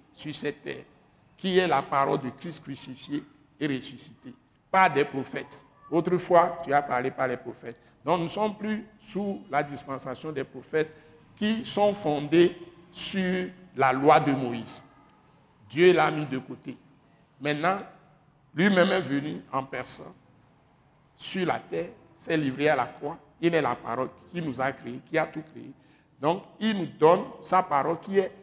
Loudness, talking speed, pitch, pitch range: -27 LUFS, 165 wpm, 150 Hz, 135-175 Hz